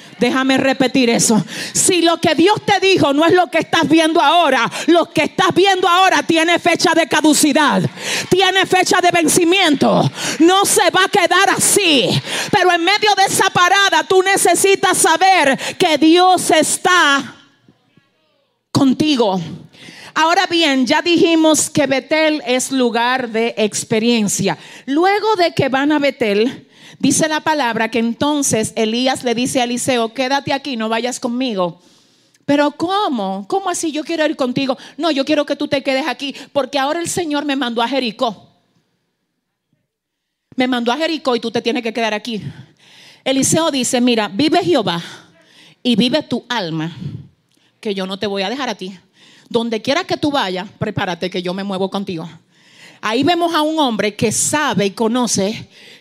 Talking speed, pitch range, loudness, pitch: 165 wpm, 230-335 Hz, -15 LUFS, 275 Hz